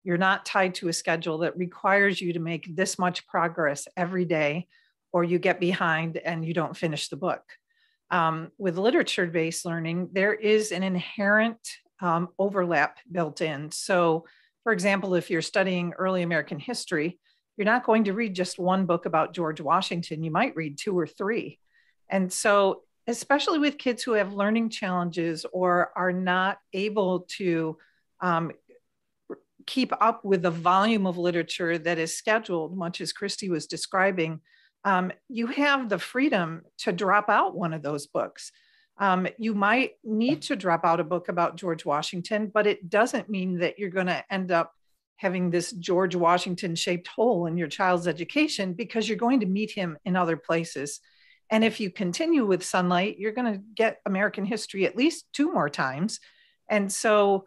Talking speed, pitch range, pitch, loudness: 175 wpm, 170-215 Hz, 185 Hz, -26 LUFS